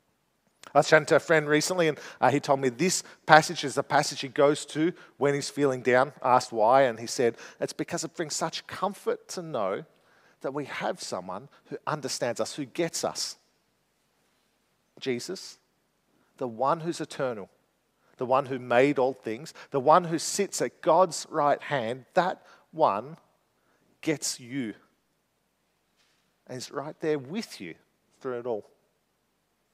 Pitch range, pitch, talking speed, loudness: 130-165 Hz, 145 Hz, 155 wpm, -27 LUFS